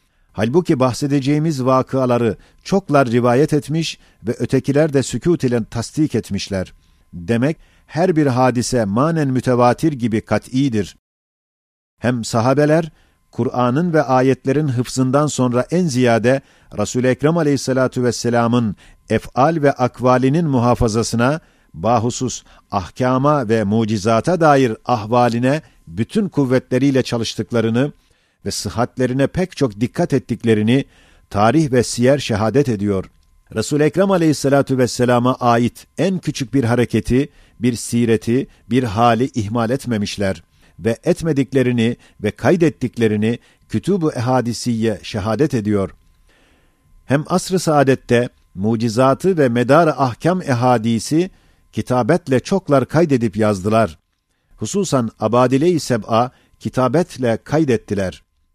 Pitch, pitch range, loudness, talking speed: 125 Hz, 110-140 Hz, -17 LUFS, 100 wpm